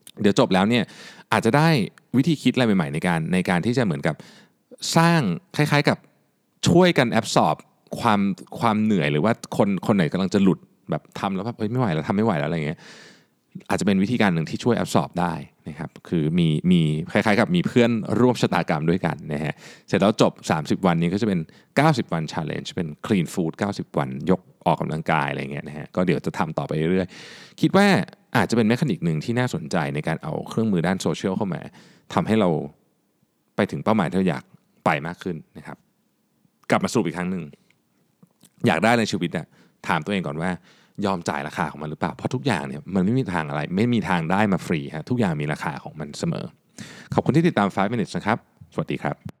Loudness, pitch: -23 LUFS, 115 Hz